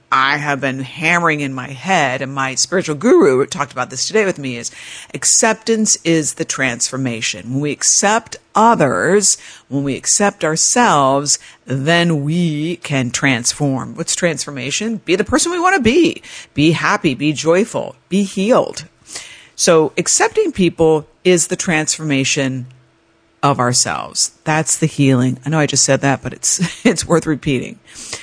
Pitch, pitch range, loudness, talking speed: 155 Hz, 135-185 Hz, -15 LUFS, 150 wpm